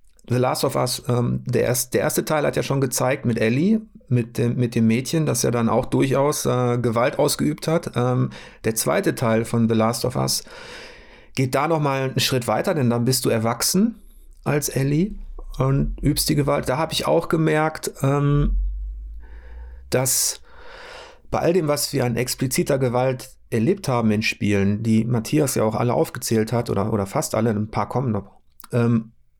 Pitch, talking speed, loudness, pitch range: 125 Hz, 190 wpm, -21 LUFS, 115-155 Hz